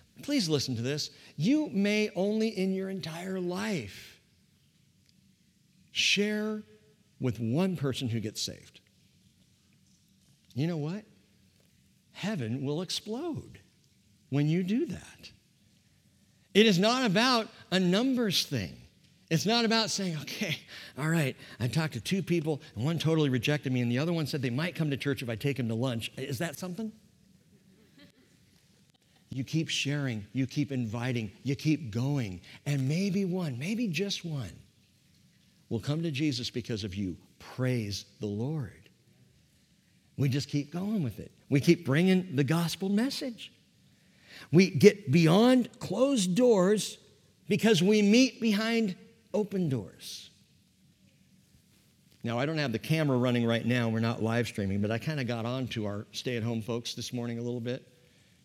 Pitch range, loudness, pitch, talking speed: 125-190 Hz, -29 LUFS, 150 Hz, 150 wpm